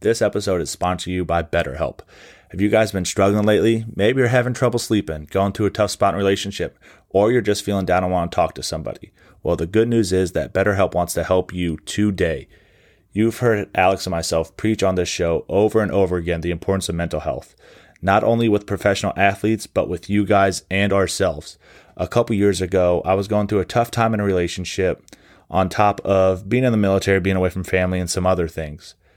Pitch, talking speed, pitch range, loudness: 95 Hz, 220 wpm, 90-105 Hz, -20 LUFS